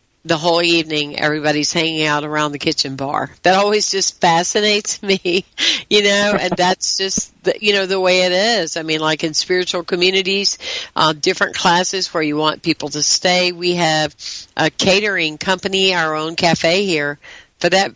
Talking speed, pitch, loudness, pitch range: 175 wpm, 180 Hz, -16 LUFS, 155-190 Hz